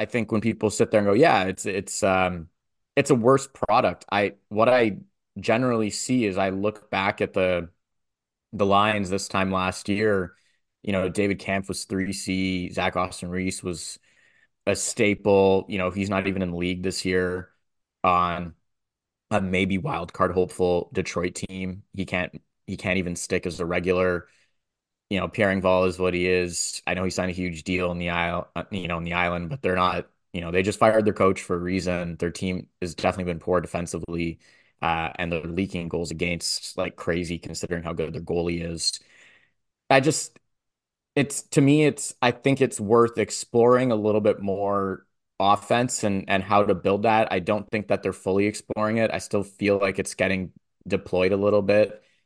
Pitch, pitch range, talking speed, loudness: 95 Hz, 90-105 Hz, 195 wpm, -24 LUFS